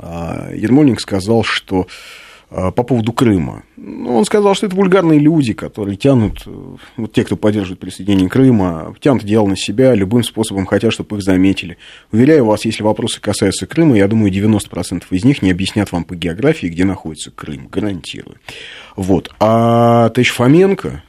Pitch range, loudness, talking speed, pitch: 95-120 Hz, -14 LUFS, 155 wpm, 105 Hz